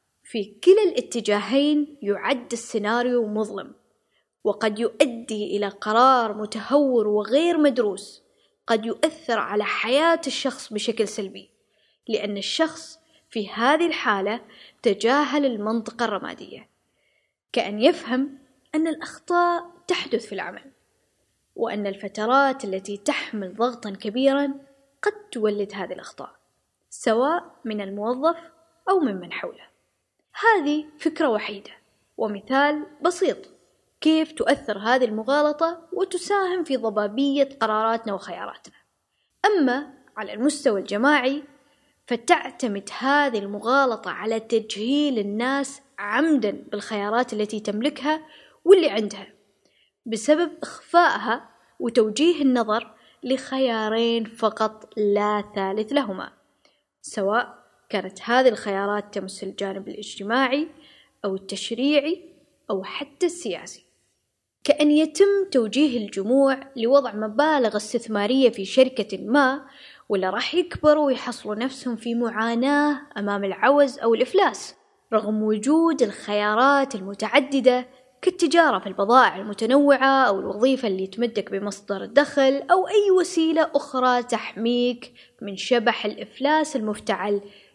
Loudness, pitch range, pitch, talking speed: -23 LUFS, 210-290 Hz, 250 Hz, 100 wpm